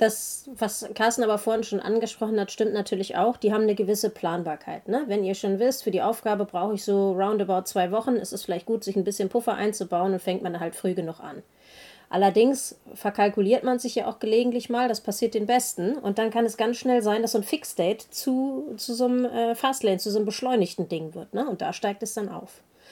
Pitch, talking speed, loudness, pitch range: 215 Hz, 235 wpm, -26 LUFS, 200-235 Hz